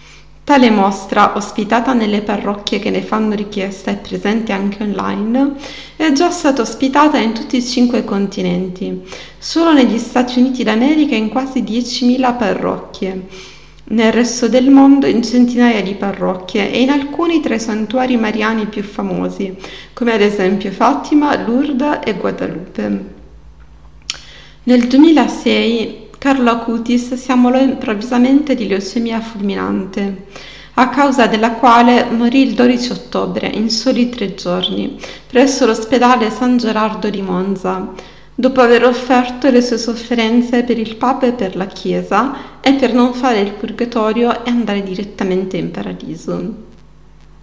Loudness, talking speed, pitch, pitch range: -14 LUFS, 135 wpm, 230 Hz, 205-250 Hz